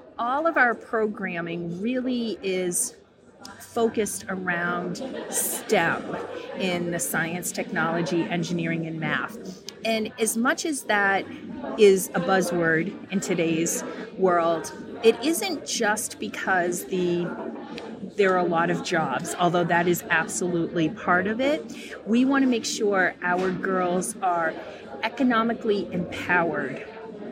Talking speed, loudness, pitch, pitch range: 120 wpm, -25 LUFS, 195 Hz, 175-230 Hz